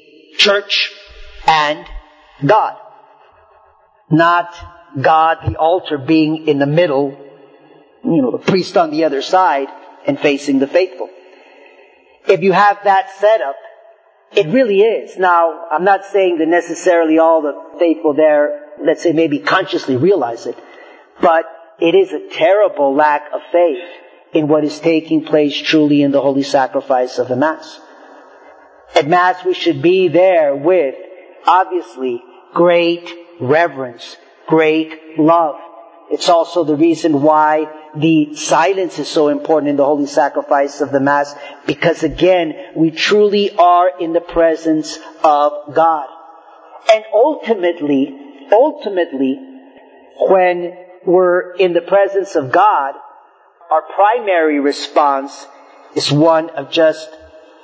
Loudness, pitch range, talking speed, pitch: -14 LUFS, 150-185 Hz, 130 wpm, 165 Hz